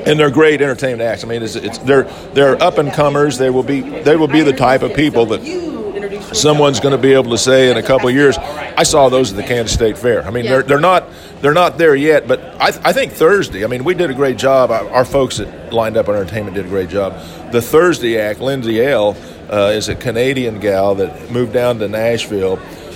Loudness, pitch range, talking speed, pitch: -13 LUFS, 110-145 Hz, 245 wpm, 130 Hz